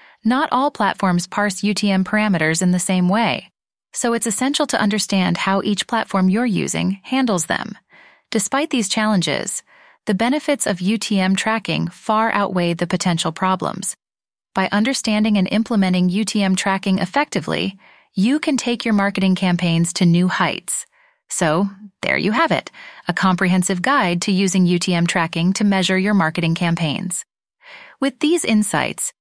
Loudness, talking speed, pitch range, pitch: -18 LUFS, 145 wpm, 185-225 Hz, 200 Hz